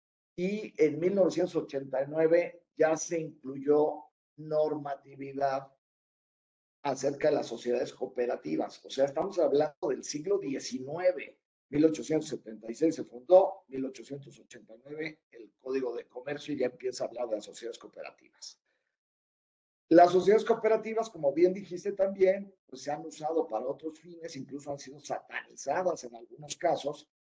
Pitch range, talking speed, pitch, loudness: 135-180 Hz, 125 wpm, 155 Hz, -30 LUFS